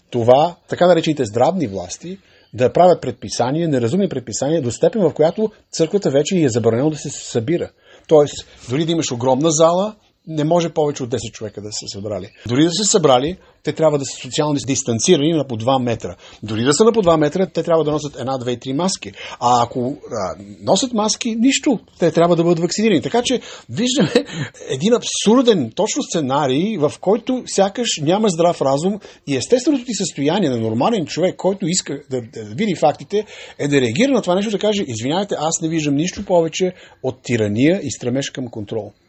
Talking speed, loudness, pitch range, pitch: 180 wpm, -18 LUFS, 130-190 Hz, 155 Hz